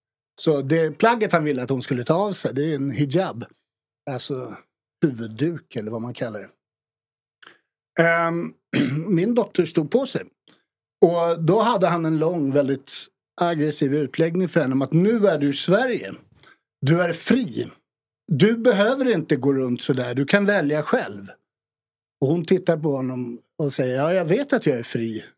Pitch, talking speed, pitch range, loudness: 155 Hz, 175 wpm, 135-175 Hz, -22 LUFS